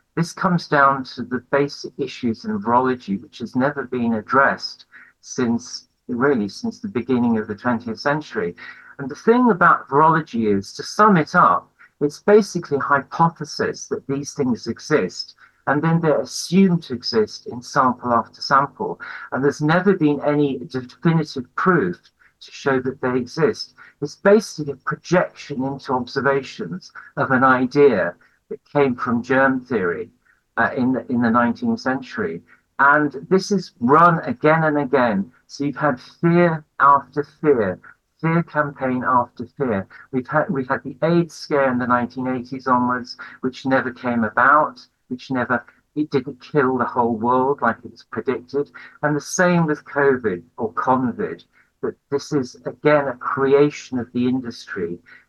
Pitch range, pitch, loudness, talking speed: 125-160 Hz, 140 Hz, -20 LUFS, 155 wpm